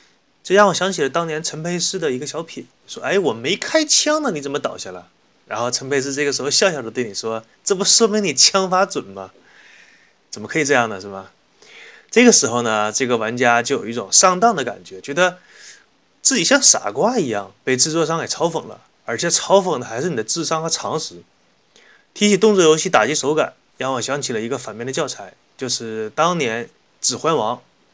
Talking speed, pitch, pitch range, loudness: 300 characters per minute, 155 Hz, 120-190 Hz, -17 LUFS